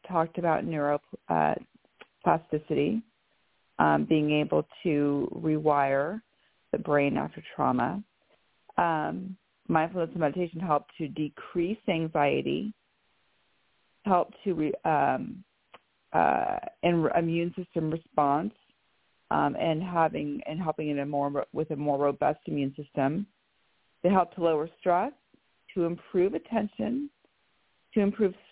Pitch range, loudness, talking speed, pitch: 150-185 Hz, -29 LUFS, 115 wpm, 165 Hz